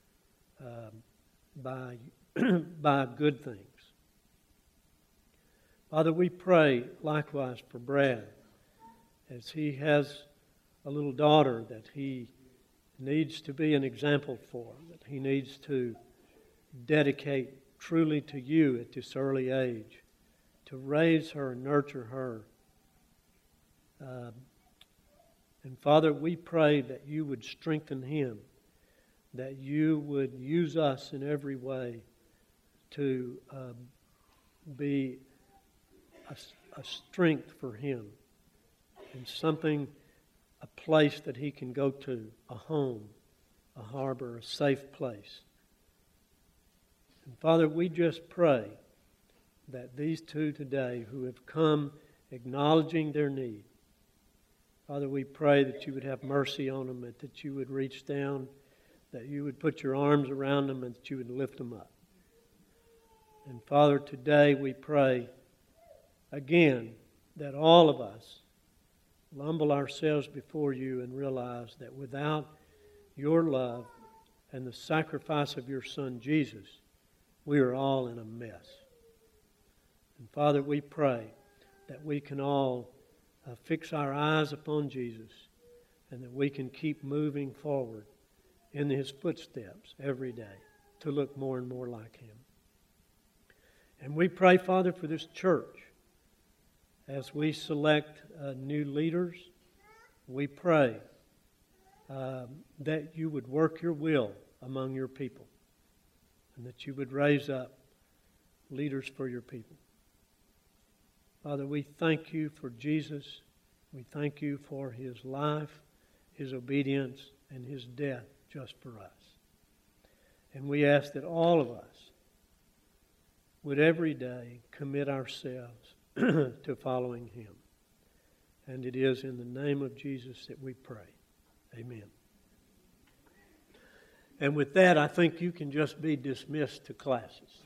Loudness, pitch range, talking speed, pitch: -31 LUFS, 125-150 Hz, 125 wpm, 140 Hz